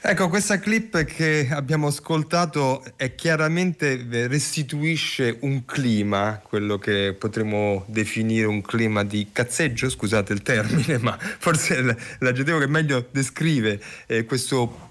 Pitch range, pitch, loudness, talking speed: 110-155 Hz, 130 Hz, -23 LUFS, 125 wpm